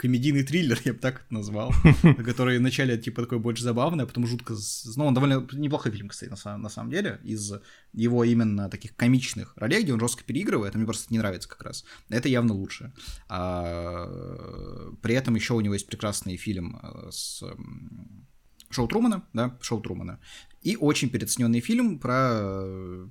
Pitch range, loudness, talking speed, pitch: 105-125 Hz, -26 LUFS, 165 wpm, 115 Hz